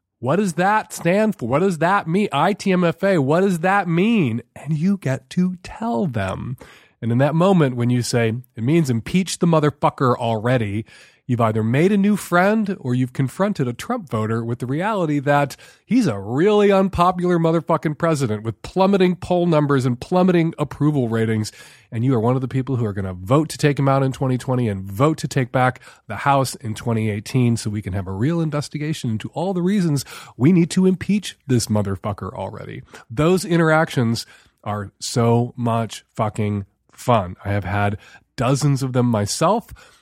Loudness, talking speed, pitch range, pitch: -20 LUFS, 185 wpm, 115-175 Hz, 135 Hz